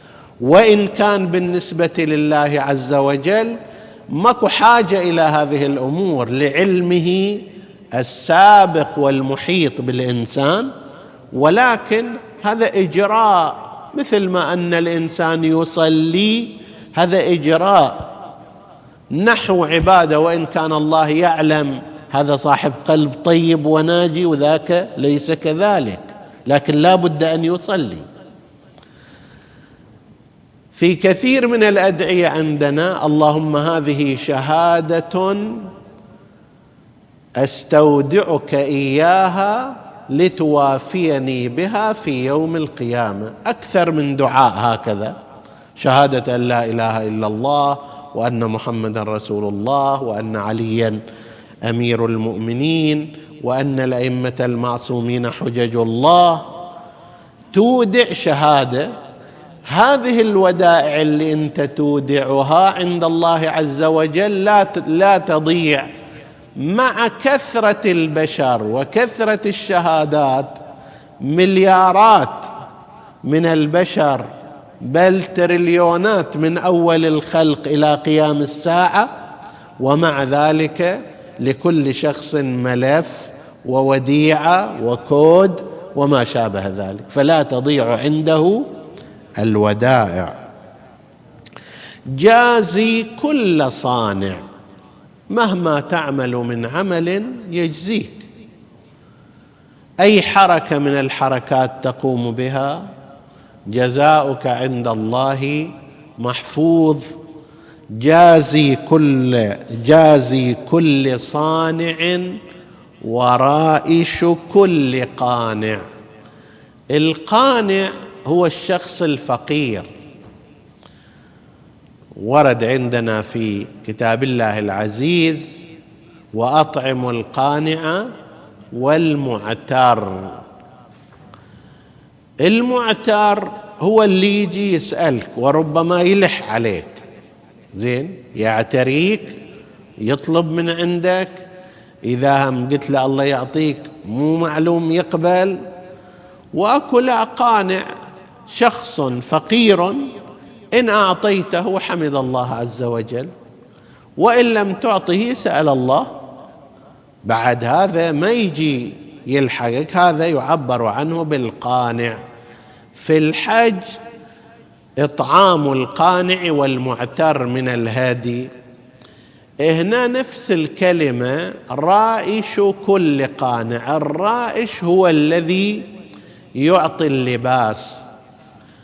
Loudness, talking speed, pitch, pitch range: -15 LUFS, 75 wpm, 155 Hz, 130-180 Hz